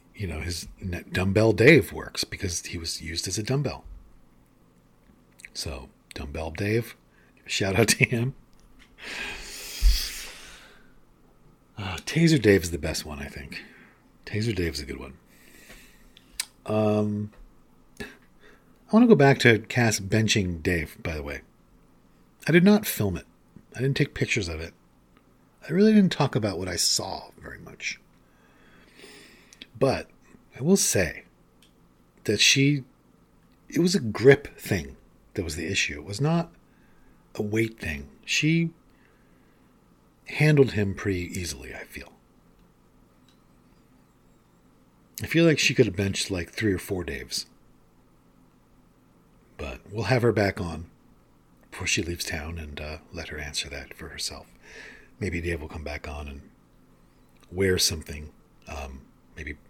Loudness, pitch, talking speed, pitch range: -25 LUFS, 95 Hz, 140 wpm, 80-120 Hz